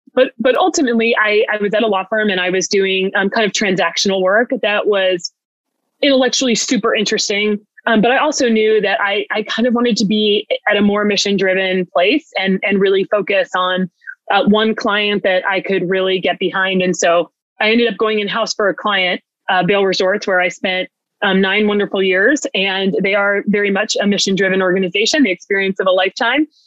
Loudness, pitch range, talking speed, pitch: -15 LUFS, 190-220 Hz, 205 wpm, 205 Hz